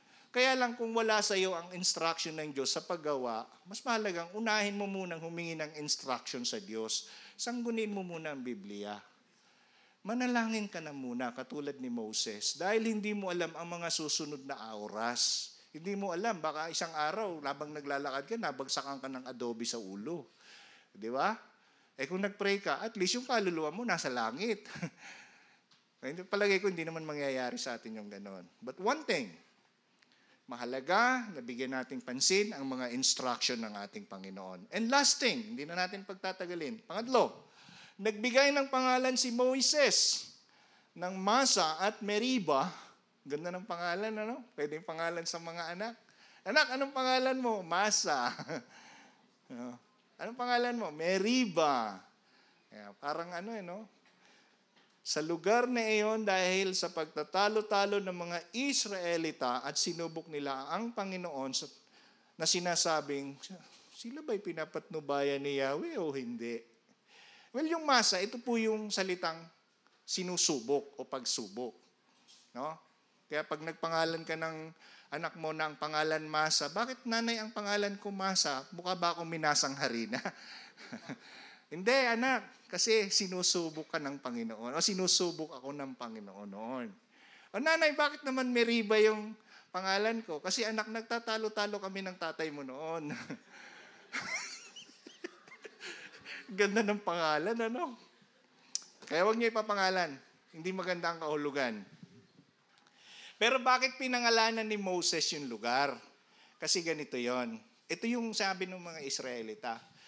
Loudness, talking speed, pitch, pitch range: -34 LUFS, 135 wpm, 180 Hz, 150-220 Hz